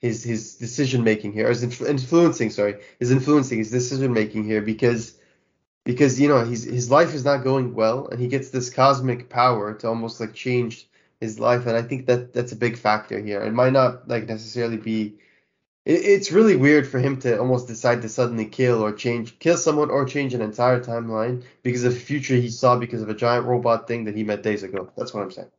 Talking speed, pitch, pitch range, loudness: 225 wpm, 120 Hz, 110-130 Hz, -22 LUFS